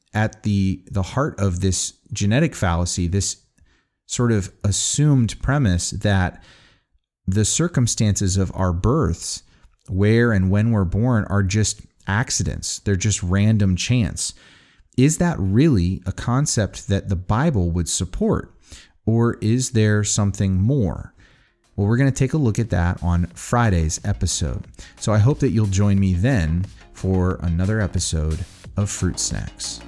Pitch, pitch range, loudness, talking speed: 100 Hz, 90-110 Hz, -20 LUFS, 145 wpm